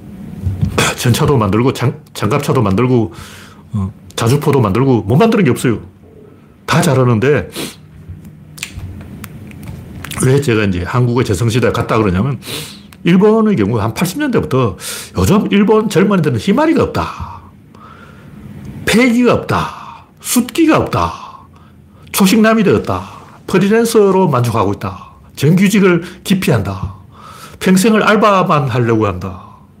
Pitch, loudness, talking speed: 140 Hz, -13 LUFS, 250 characters per minute